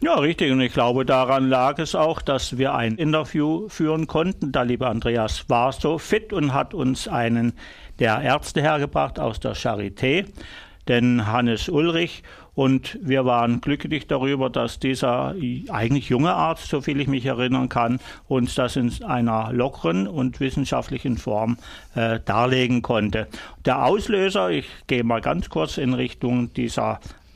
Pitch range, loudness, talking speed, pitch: 120-145 Hz, -22 LUFS, 155 wpm, 130 Hz